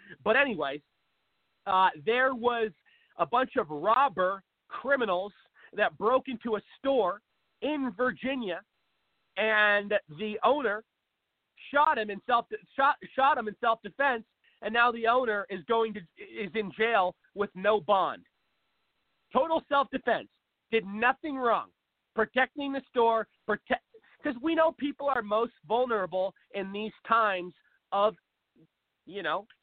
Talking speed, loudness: 135 wpm, -29 LUFS